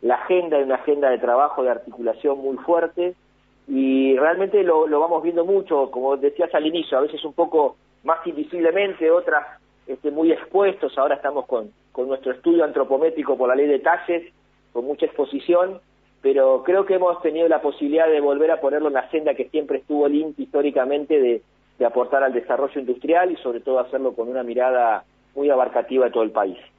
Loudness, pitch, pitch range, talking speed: -21 LUFS, 145 Hz, 130-165 Hz, 190 wpm